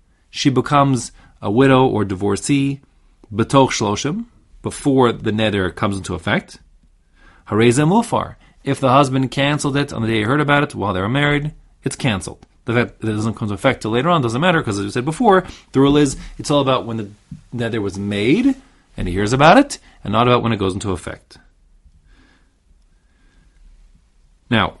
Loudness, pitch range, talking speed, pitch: -17 LUFS, 100-140 Hz, 175 wpm, 115 Hz